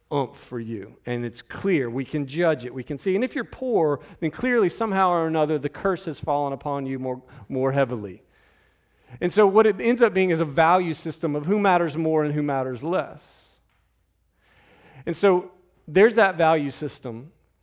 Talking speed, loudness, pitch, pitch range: 190 wpm, -23 LUFS, 160 Hz, 135-185 Hz